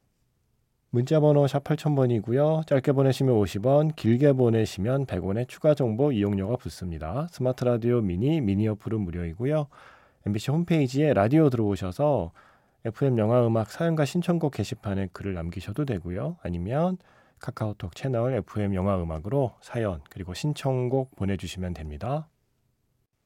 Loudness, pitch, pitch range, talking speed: -26 LUFS, 120 Hz, 100-140 Hz, 330 characters per minute